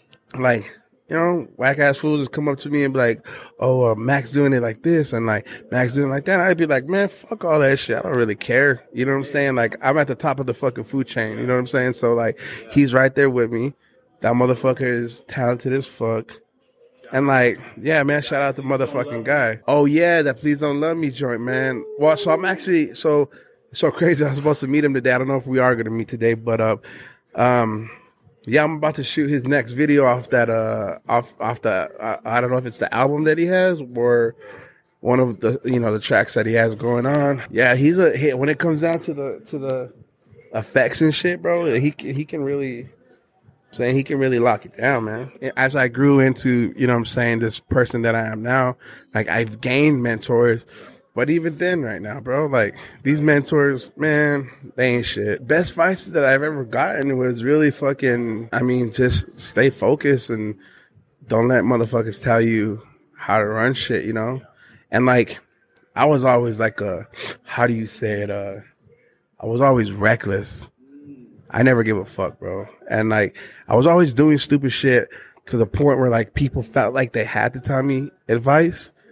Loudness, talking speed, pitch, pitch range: -19 LUFS, 220 wpm, 130 Hz, 120-145 Hz